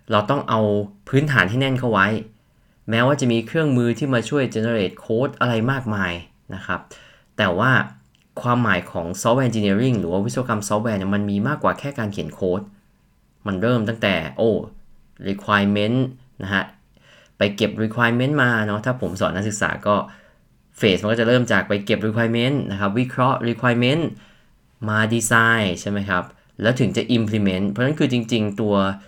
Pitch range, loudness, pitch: 100-125 Hz, -20 LUFS, 110 Hz